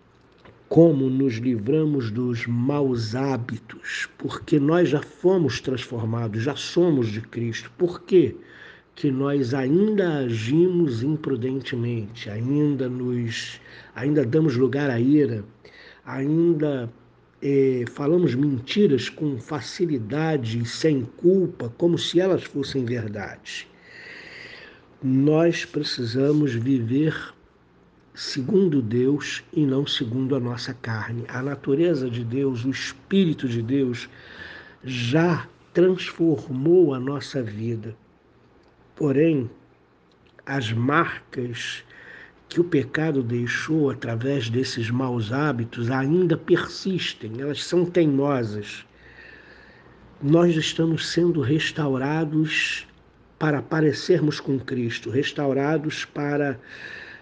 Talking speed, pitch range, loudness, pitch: 100 wpm, 125-160 Hz, -23 LUFS, 140 Hz